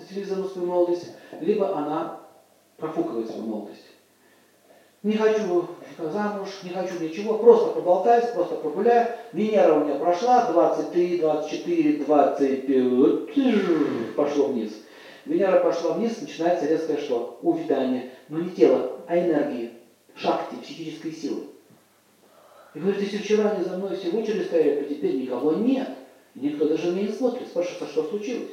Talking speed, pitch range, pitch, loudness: 135 wpm, 155-220 Hz, 175 Hz, -24 LUFS